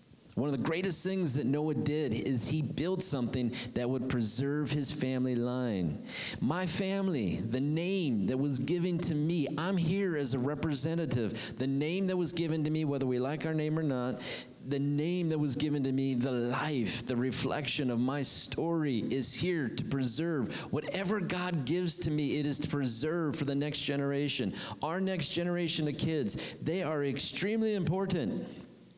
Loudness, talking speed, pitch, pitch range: -32 LUFS, 180 wpm, 150 Hz, 135-170 Hz